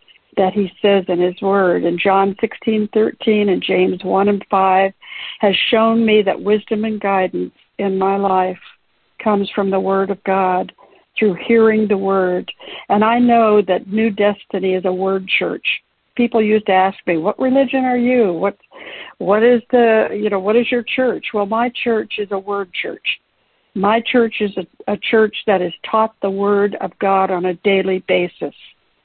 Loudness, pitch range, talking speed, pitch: -16 LUFS, 190-220 Hz, 180 wpm, 205 Hz